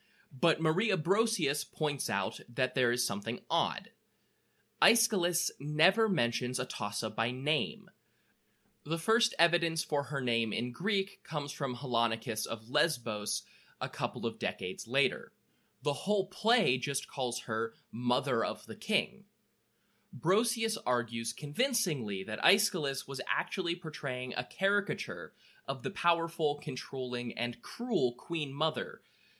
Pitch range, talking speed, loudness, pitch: 125-190 Hz, 125 wpm, -32 LUFS, 145 Hz